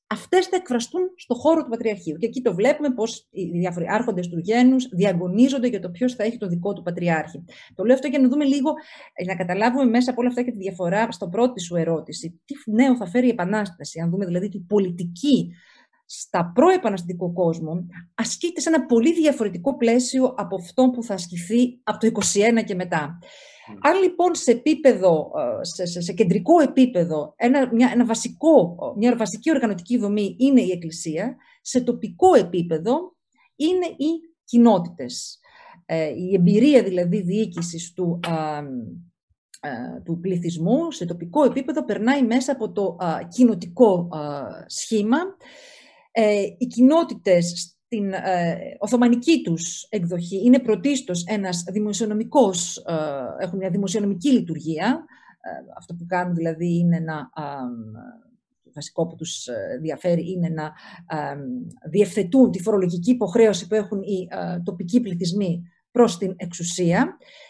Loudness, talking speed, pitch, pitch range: -21 LUFS, 150 wpm, 210 Hz, 175-250 Hz